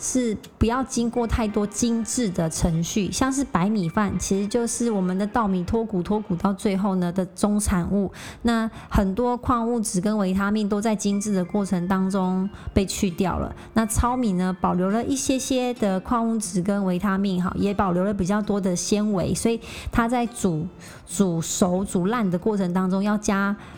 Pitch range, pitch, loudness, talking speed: 185-225 Hz, 205 Hz, -23 LUFS, 270 characters per minute